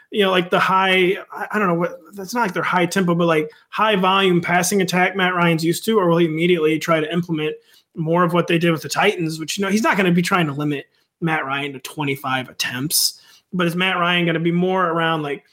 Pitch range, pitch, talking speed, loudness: 160-190 Hz, 175 Hz, 245 wpm, -19 LUFS